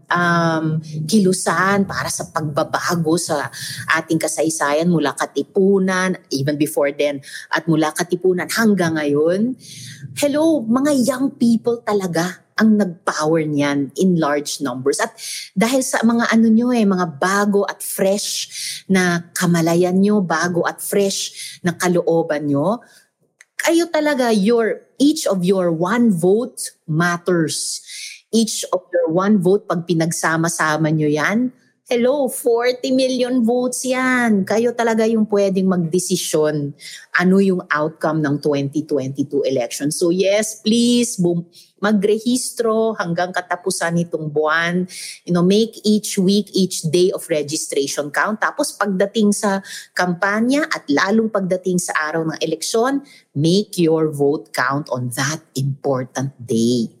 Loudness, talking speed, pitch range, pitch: -18 LUFS, 125 wpm, 155-215 Hz, 180 Hz